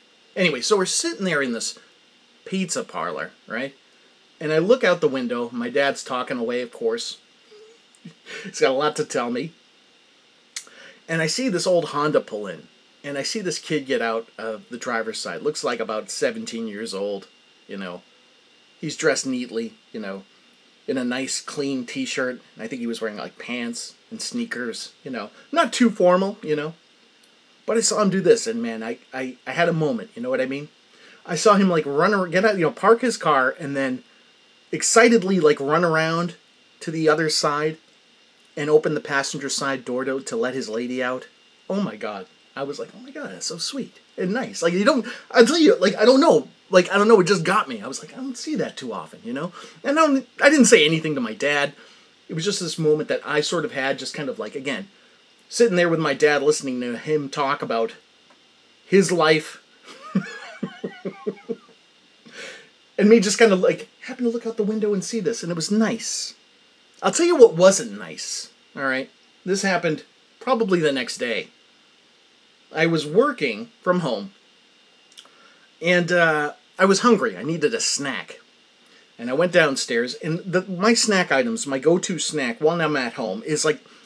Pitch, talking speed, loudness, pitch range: 185 Hz, 200 wpm, -21 LUFS, 150-235 Hz